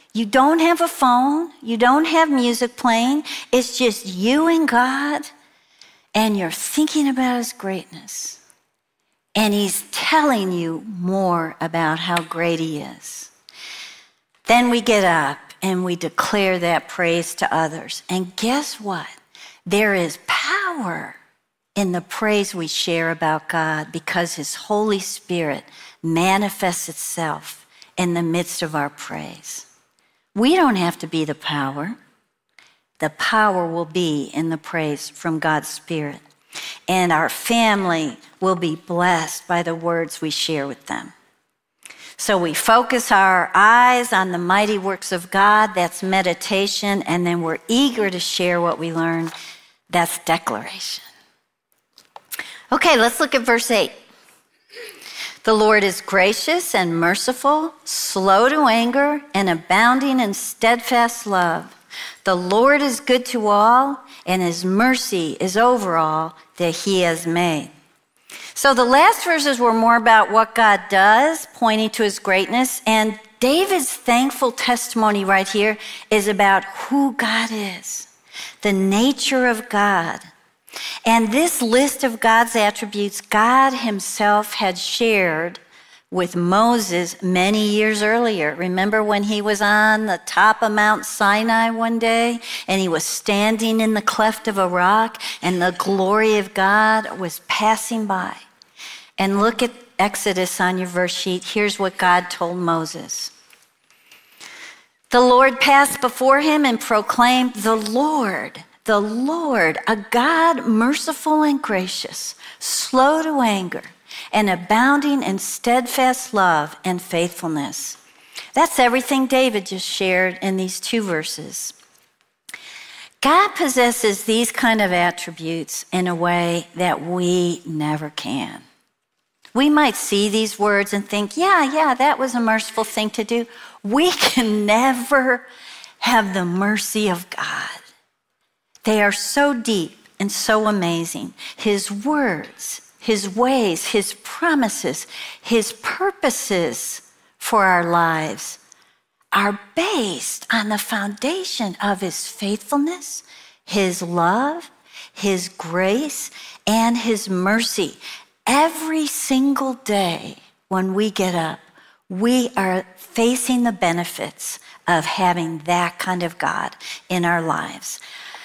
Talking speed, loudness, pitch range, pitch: 130 wpm, -19 LUFS, 180-245 Hz, 210 Hz